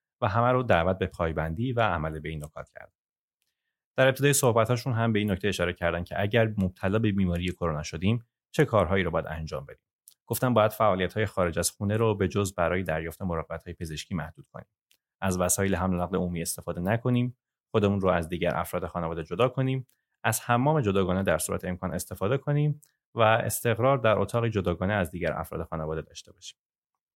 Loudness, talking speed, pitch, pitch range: -27 LUFS, 190 wpm, 95 Hz, 85-115 Hz